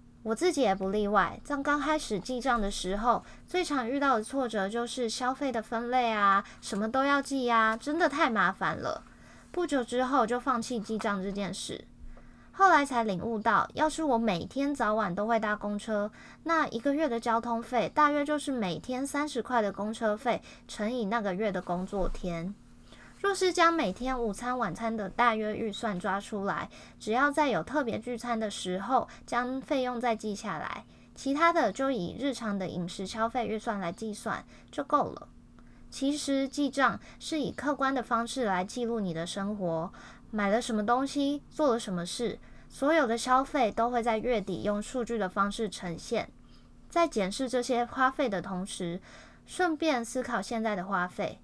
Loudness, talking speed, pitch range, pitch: -30 LUFS, 260 characters per minute, 205-270 Hz, 235 Hz